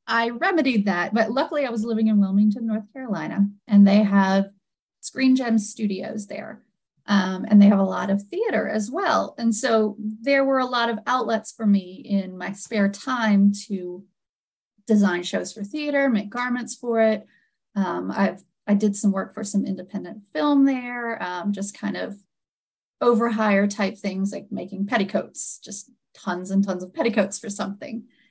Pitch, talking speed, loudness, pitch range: 210 Hz, 170 wpm, -23 LUFS, 200-230 Hz